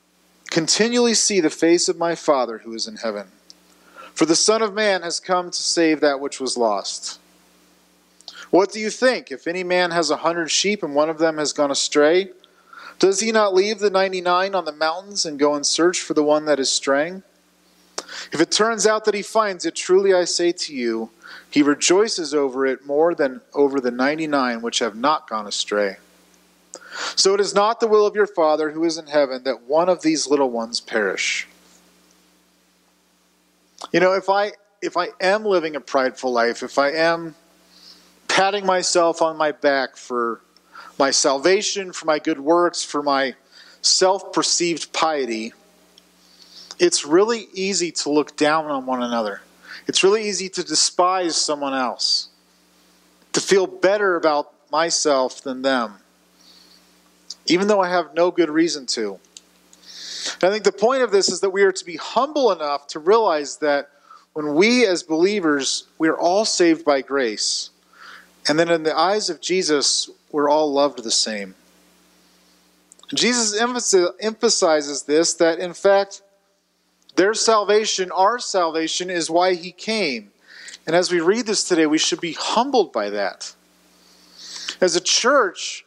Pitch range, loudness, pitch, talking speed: 120-190 Hz, -19 LUFS, 160 Hz, 170 wpm